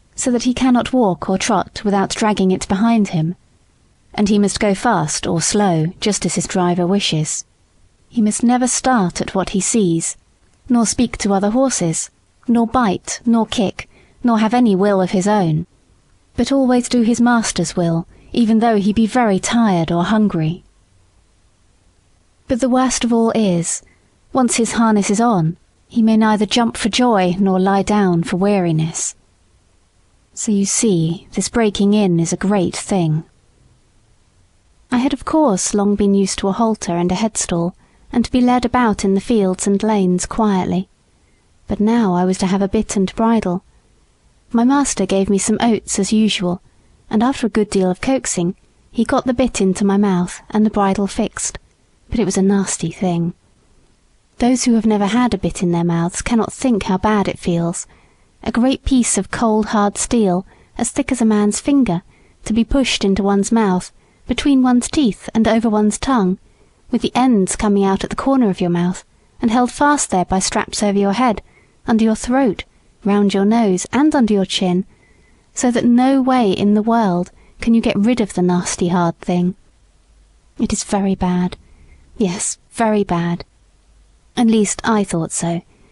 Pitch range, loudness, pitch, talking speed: 180-230 Hz, -16 LUFS, 205 Hz, 180 wpm